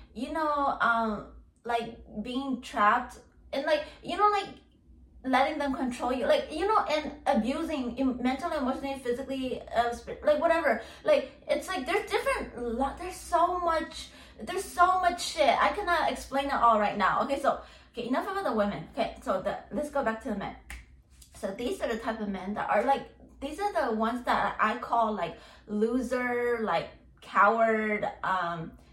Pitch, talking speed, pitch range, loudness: 260 Hz, 175 wpm, 225-305 Hz, -29 LUFS